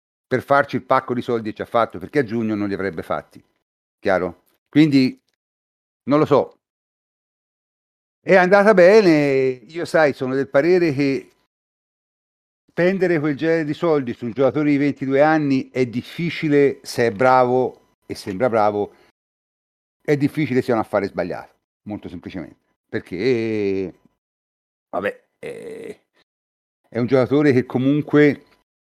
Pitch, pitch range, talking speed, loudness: 130 Hz, 105-150 Hz, 135 wpm, -19 LUFS